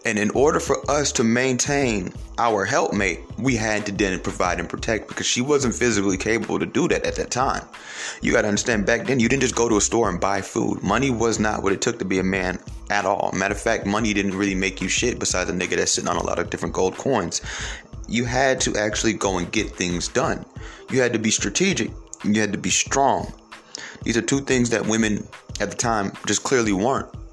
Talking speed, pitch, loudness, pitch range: 235 wpm, 110 Hz, -22 LUFS, 100-120 Hz